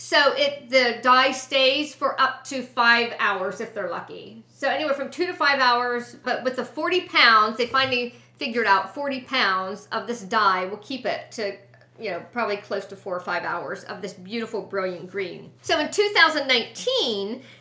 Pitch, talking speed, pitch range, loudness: 250 Hz, 185 wpm, 210-275 Hz, -22 LUFS